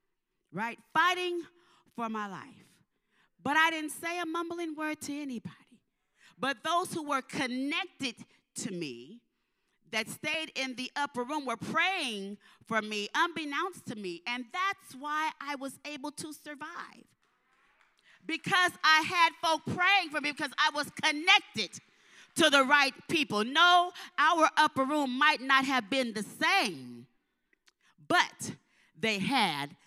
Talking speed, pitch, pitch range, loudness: 140 wpm, 295 Hz, 245-325 Hz, -29 LUFS